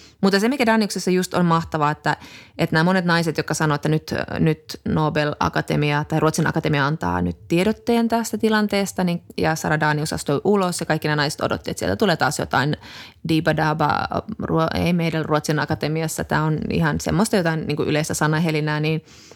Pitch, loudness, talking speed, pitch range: 160 Hz, -21 LUFS, 175 wpm, 150-185 Hz